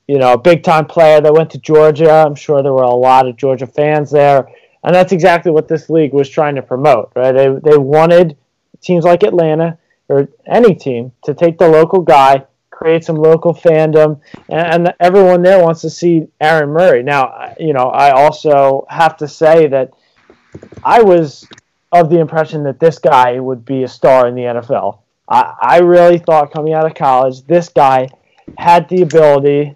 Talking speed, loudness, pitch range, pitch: 190 wpm, -10 LUFS, 135-170 Hz, 155 Hz